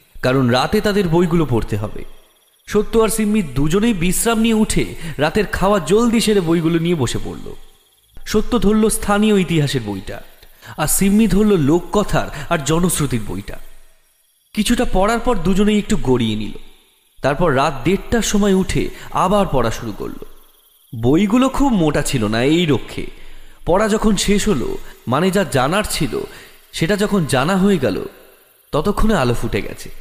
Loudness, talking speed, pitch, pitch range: -17 LUFS, 145 wpm, 185 Hz, 135-210 Hz